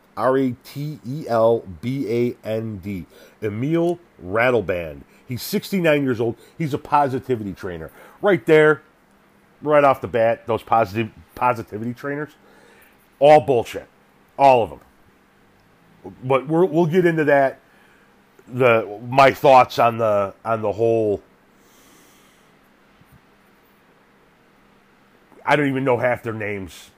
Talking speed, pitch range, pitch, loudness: 125 wpm, 110-145 Hz, 125 Hz, -19 LUFS